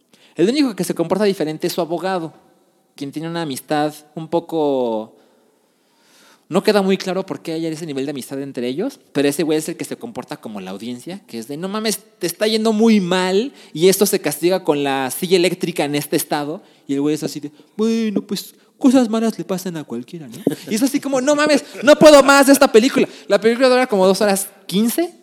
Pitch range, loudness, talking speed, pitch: 150-220 Hz, -17 LUFS, 225 wpm, 185 Hz